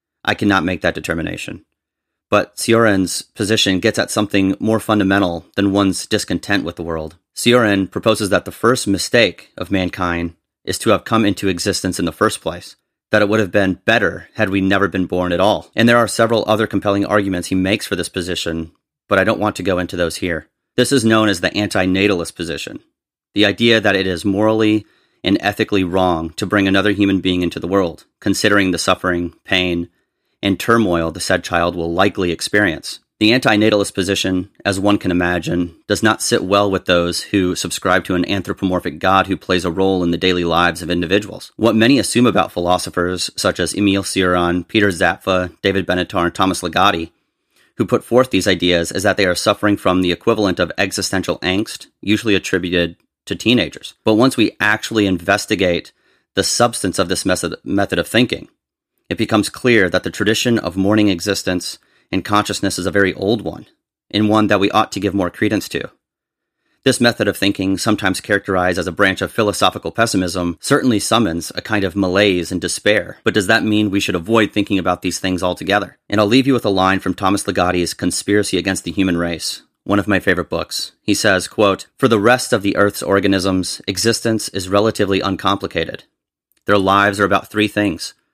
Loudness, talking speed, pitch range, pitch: -16 LUFS, 190 wpm, 90-105 Hz, 95 Hz